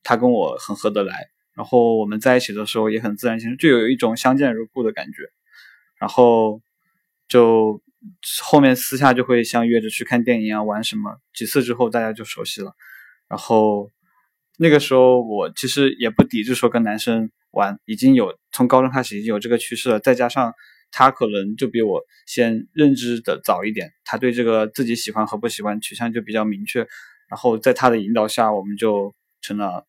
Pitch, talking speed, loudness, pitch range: 120 Hz, 295 characters per minute, -19 LUFS, 110-130 Hz